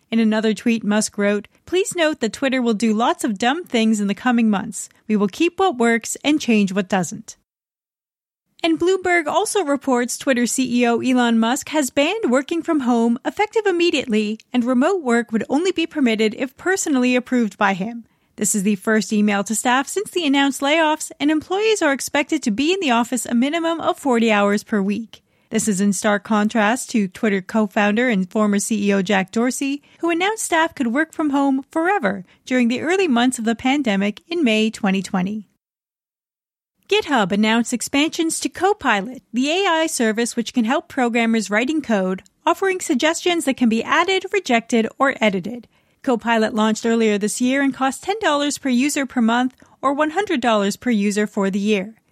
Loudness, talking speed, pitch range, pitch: -19 LUFS, 180 wpm, 220-305 Hz, 245 Hz